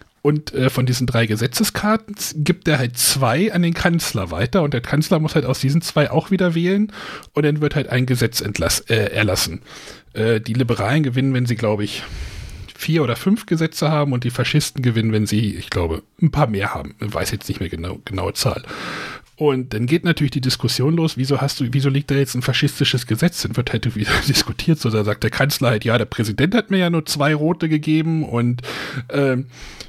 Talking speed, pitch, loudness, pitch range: 215 wpm, 130 Hz, -19 LUFS, 115-155 Hz